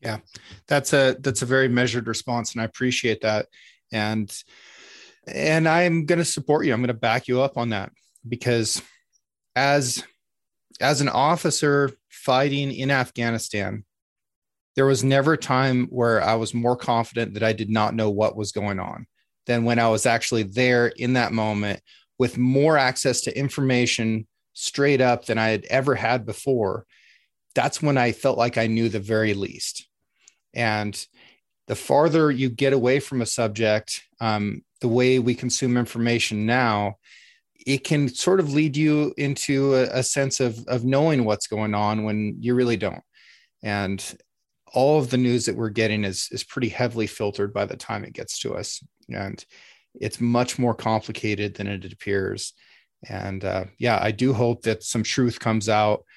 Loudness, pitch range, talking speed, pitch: -23 LUFS, 110-130 Hz, 170 wpm, 120 Hz